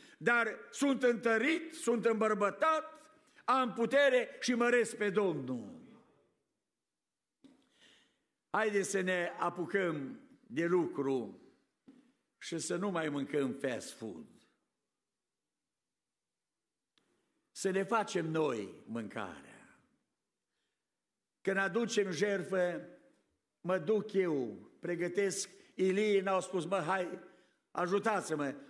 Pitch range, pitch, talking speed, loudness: 180-245 Hz, 200 Hz, 90 wpm, -34 LUFS